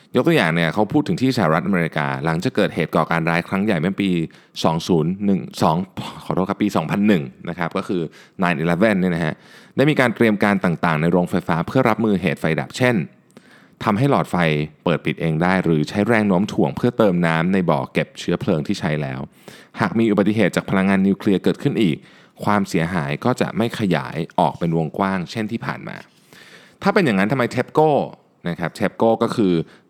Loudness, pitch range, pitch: -20 LUFS, 85-105 Hz, 95 Hz